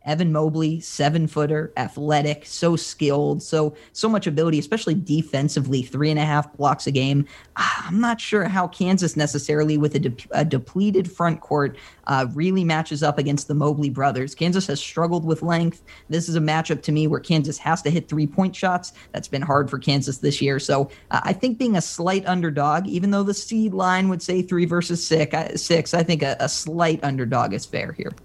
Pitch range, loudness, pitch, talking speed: 145-175 Hz, -22 LUFS, 155 Hz, 200 wpm